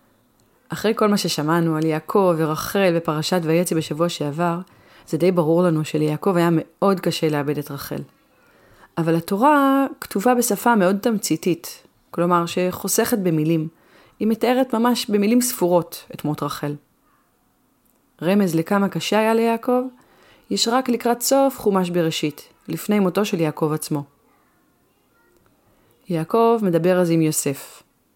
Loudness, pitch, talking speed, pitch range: -20 LUFS, 180 Hz, 130 wpm, 160-215 Hz